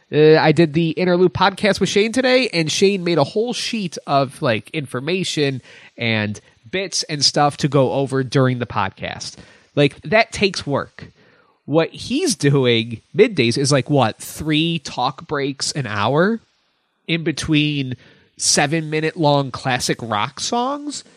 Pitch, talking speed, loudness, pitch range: 155 Hz, 145 wpm, -18 LUFS, 135-180 Hz